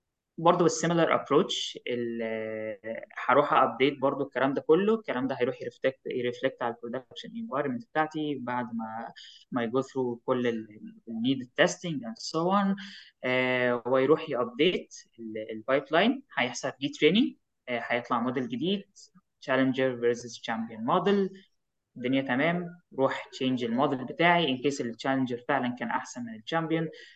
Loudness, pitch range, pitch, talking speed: -28 LUFS, 120-170 Hz, 135 Hz, 125 wpm